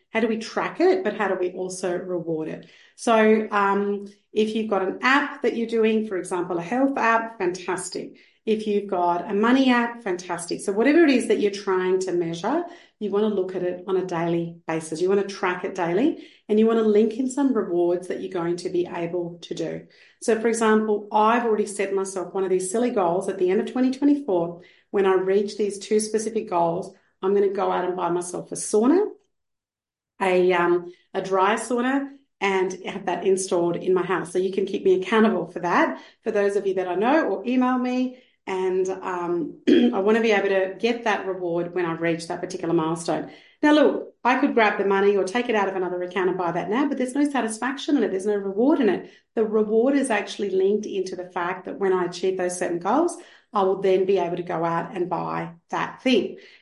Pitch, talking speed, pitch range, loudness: 195 Hz, 225 wpm, 180-225 Hz, -23 LUFS